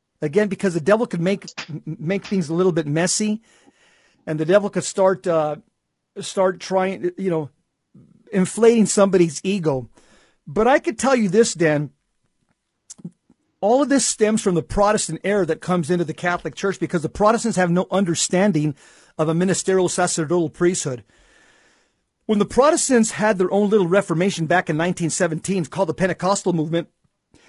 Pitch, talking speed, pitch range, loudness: 185 Hz, 160 wpm, 165-205 Hz, -20 LUFS